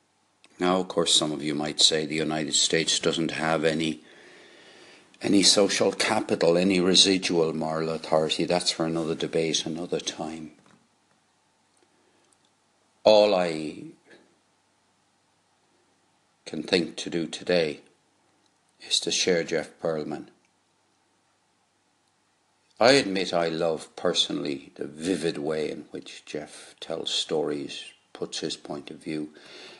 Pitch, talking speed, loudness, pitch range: 80 Hz, 115 wpm, -24 LUFS, 80-90 Hz